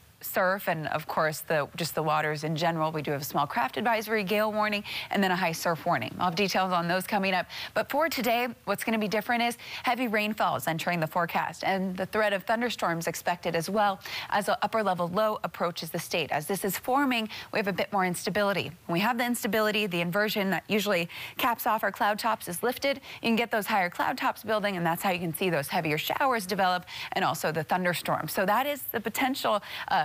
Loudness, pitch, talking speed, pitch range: -28 LUFS, 195 Hz, 230 wpm, 170-220 Hz